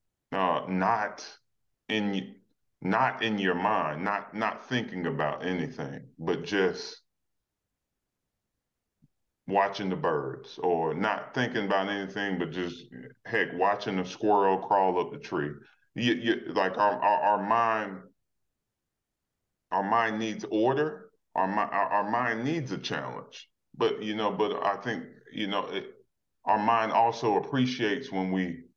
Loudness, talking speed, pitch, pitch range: -29 LUFS, 135 wpm, 105 Hz, 95-115 Hz